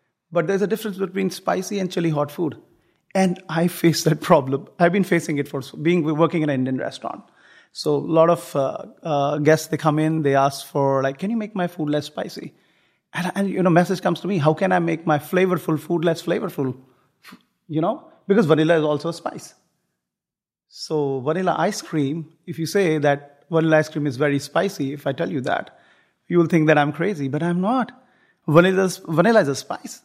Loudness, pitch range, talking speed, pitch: -21 LUFS, 150-185 Hz, 210 wpm, 165 Hz